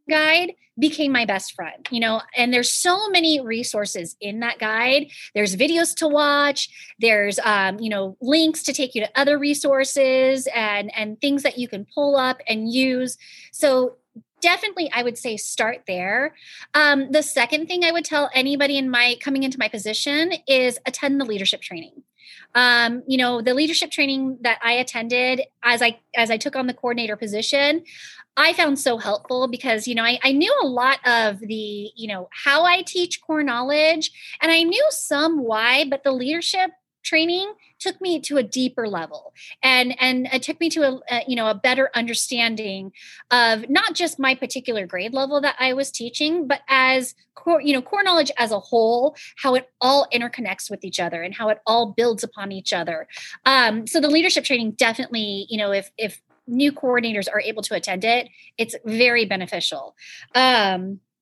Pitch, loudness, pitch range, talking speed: 255 Hz, -20 LUFS, 225-290 Hz, 185 wpm